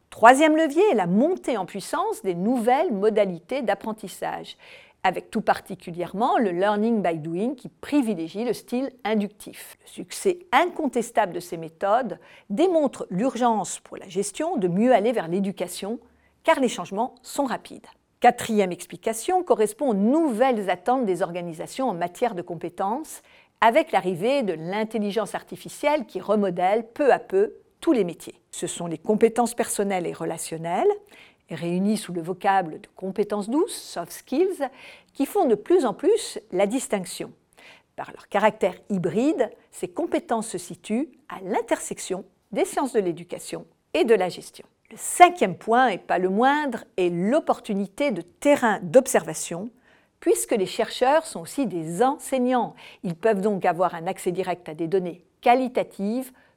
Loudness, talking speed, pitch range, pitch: -24 LUFS, 150 wpm, 185-275 Hz, 225 Hz